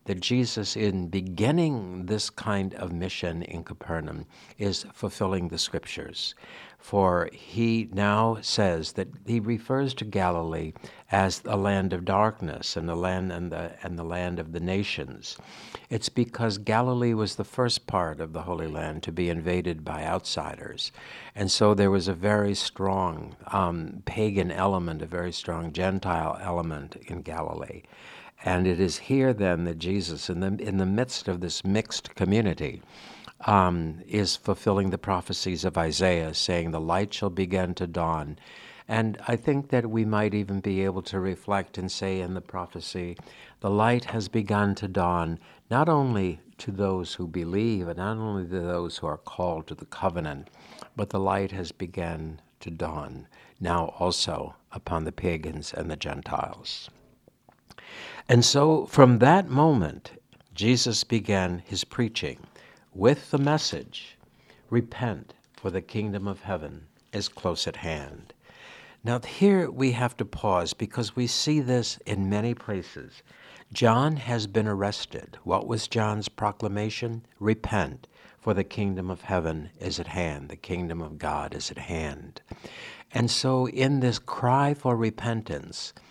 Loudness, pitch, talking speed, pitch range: -27 LUFS, 95 Hz, 155 wpm, 90-110 Hz